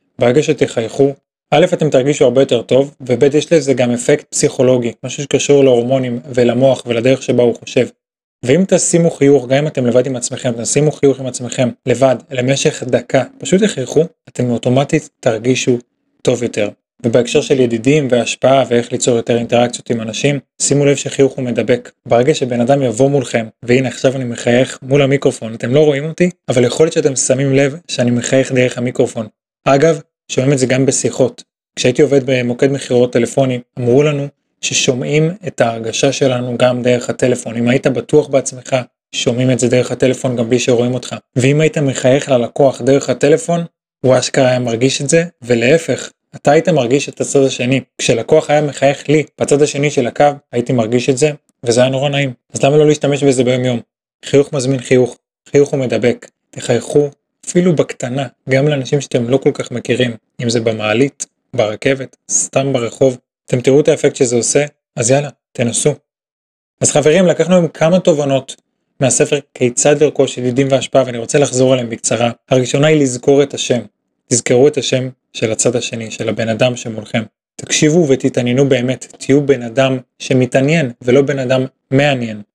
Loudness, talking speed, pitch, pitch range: -14 LUFS, 160 wpm, 135 Hz, 125-145 Hz